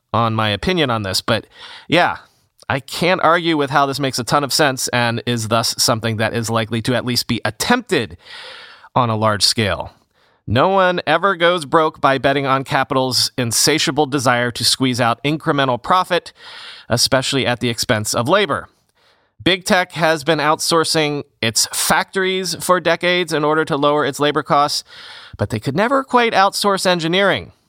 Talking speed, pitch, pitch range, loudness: 170 wpm, 140 Hz, 120-165 Hz, -16 LUFS